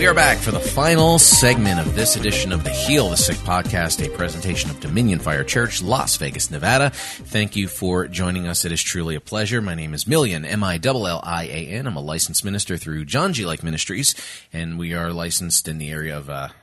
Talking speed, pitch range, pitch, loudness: 210 wpm, 80-105 Hz, 85 Hz, -19 LUFS